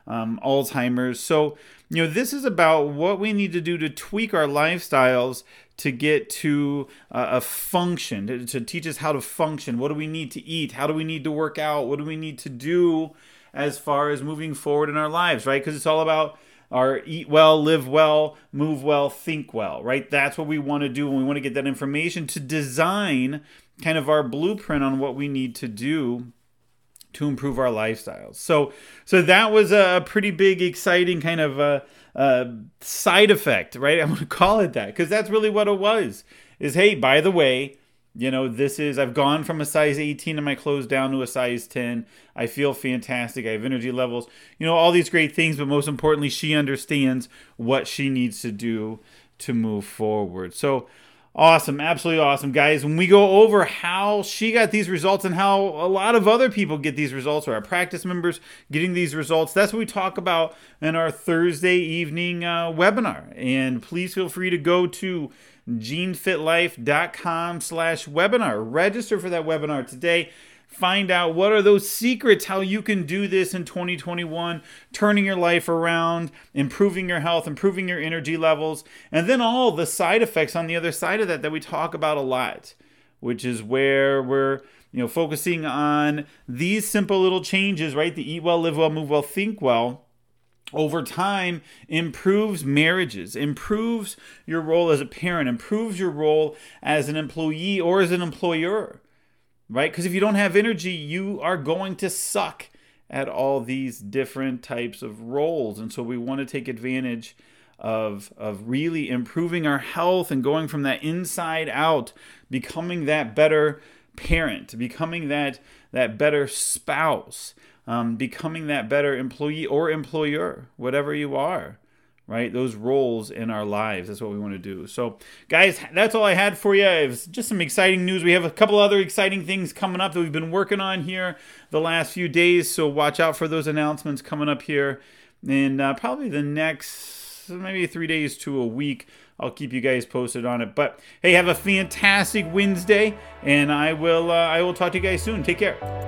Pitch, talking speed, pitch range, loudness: 155 Hz, 190 wpm, 135-180 Hz, -22 LUFS